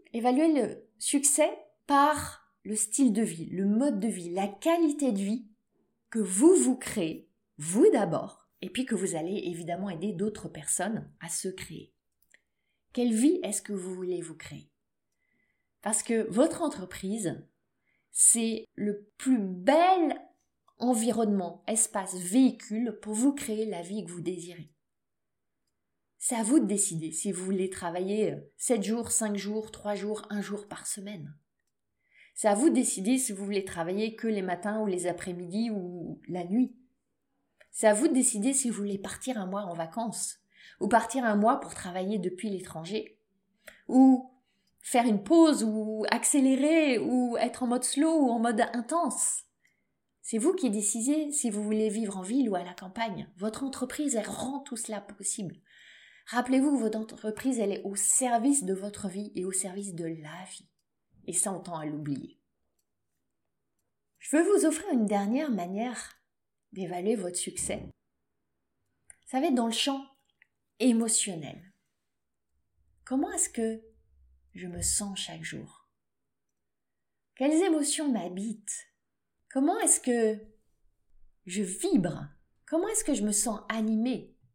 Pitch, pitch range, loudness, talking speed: 215 Hz, 190-255 Hz, -28 LUFS, 155 wpm